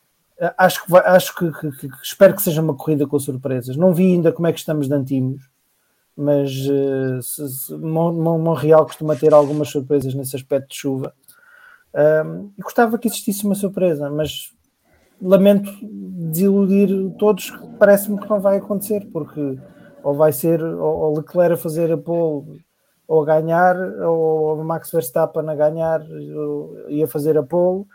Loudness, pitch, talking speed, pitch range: -18 LUFS, 160 Hz, 160 wpm, 150-185 Hz